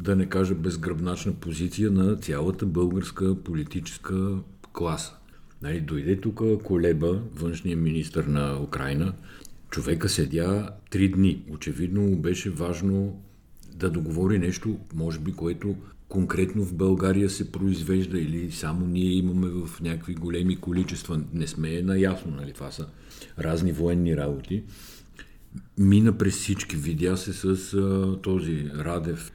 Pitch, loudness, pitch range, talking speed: 90 Hz, -27 LUFS, 85-95 Hz, 125 wpm